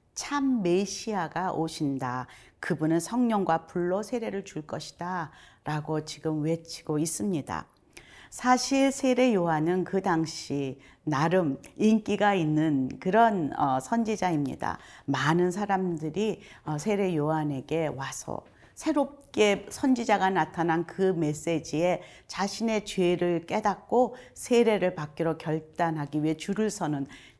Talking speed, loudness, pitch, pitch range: 245 characters per minute, -28 LUFS, 175 Hz, 155-205 Hz